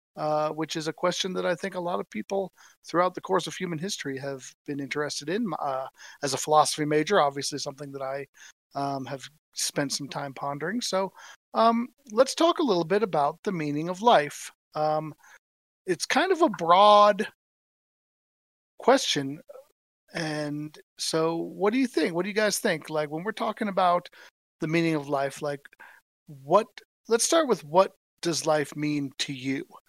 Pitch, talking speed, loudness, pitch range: 165 Hz, 175 wpm, -26 LUFS, 145-205 Hz